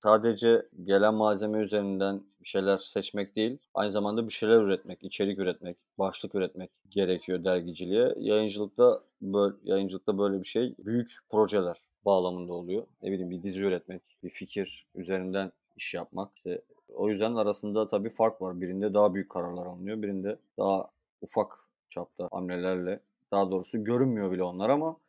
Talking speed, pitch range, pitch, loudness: 150 wpm, 95-110 Hz, 100 Hz, -30 LUFS